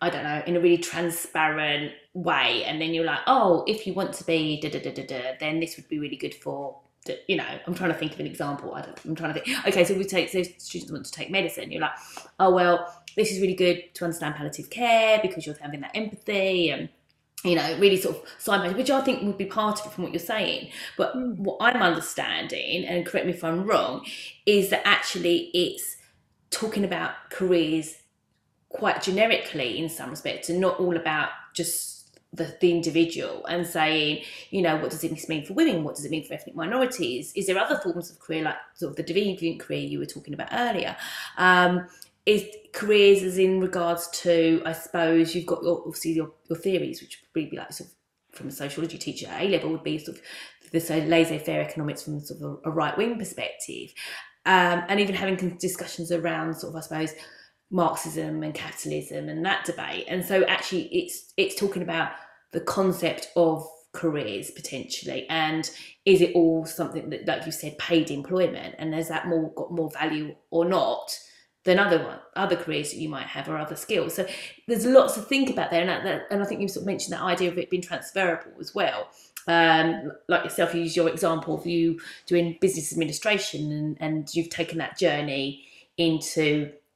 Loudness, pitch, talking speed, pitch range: -26 LUFS, 170 Hz, 205 wpm, 160-190 Hz